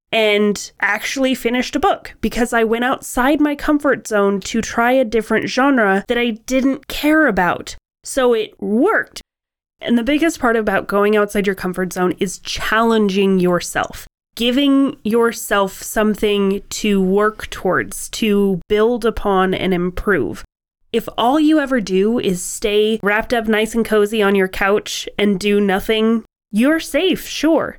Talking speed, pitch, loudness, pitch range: 150 wpm, 220 Hz, -17 LUFS, 200-250 Hz